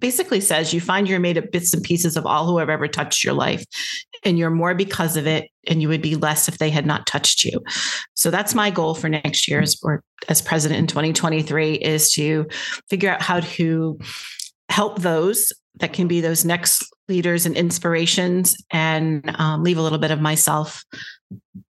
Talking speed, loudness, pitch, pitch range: 200 wpm, -19 LUFS, 165 Hz, 155-180 Hz